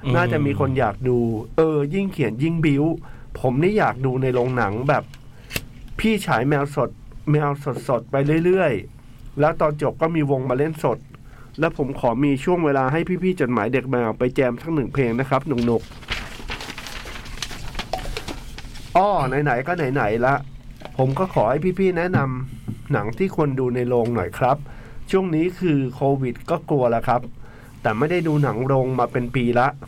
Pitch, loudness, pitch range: 135 Hz, -22 LUFS, 125-155 Hz